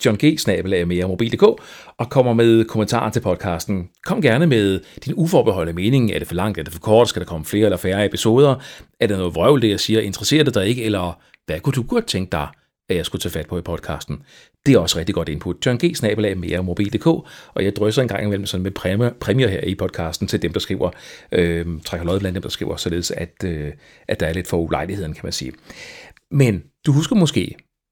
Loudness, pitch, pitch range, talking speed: -19 LUFS, 100 Hz, 90-120 Hz, 235 wpm